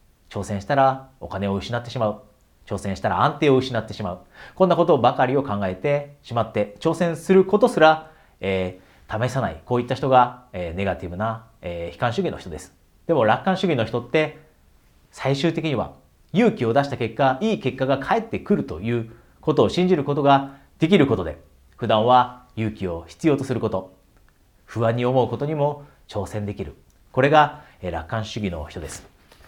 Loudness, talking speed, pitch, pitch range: -22 LUFS, 355 characters per minute, 120 Hz, 95-140 Hz